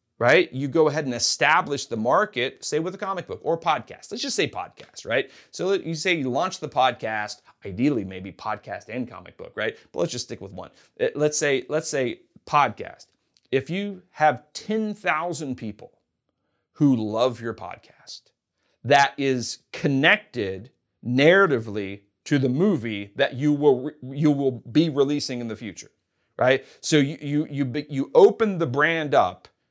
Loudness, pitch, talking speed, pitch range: -23 LUFS, 140 Hz, 165 wpm, 120-155 Hz